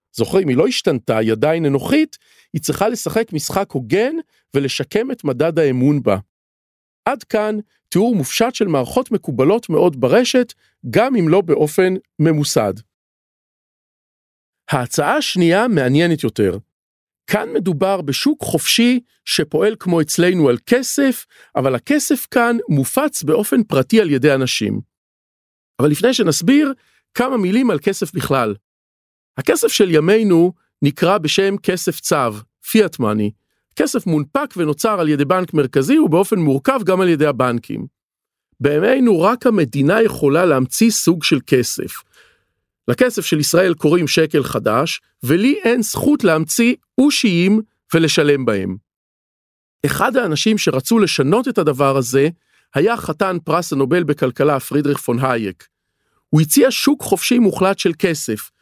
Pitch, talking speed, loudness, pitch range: 175 Hz, 130 wpm, -16 LUFS, 145-225 Hz